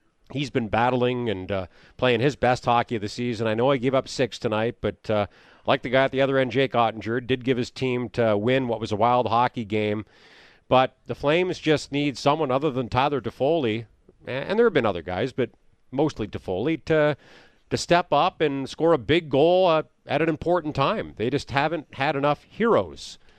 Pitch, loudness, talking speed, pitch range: 130 Hz, -24 LUFS, 210 wpm, 115-145 Hz